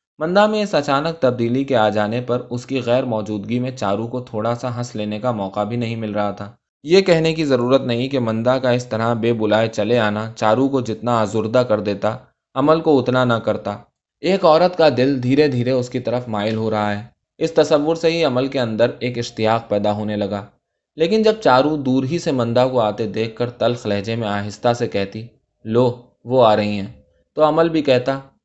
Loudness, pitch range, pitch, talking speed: -18 LUFS, 110-135 Hz, 120 Hz, 215 wpm